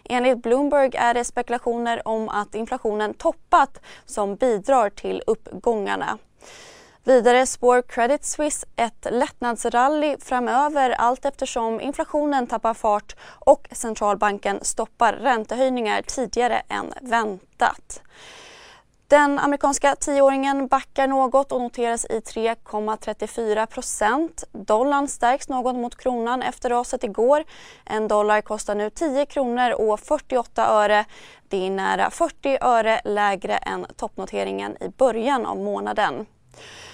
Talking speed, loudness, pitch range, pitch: 115 wpm, -22 LUFS, 220-275 Hz, 245 Hz